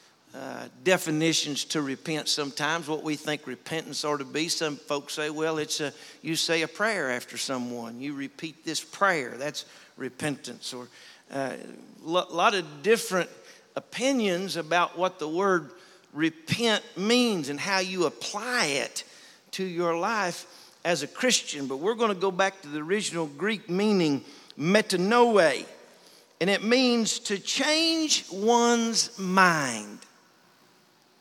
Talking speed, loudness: 140 wpm, -26 LUFS